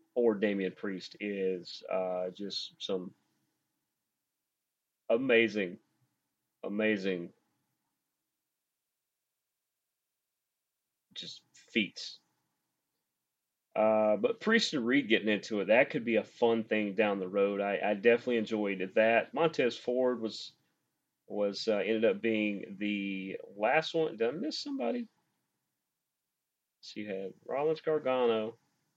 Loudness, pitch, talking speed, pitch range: -31 LUFS, 110 Hz, 110 wpm, 100-125 Hz